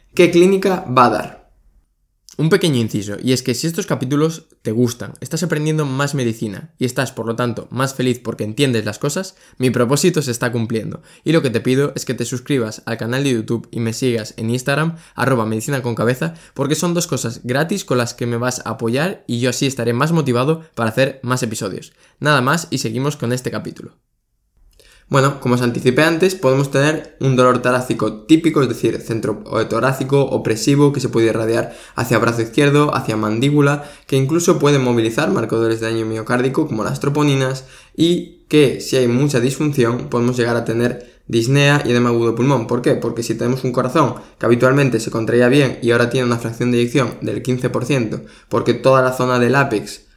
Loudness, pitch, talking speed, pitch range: -17 LUFS, 125 Hz, 195 wpm, 115-145 Hz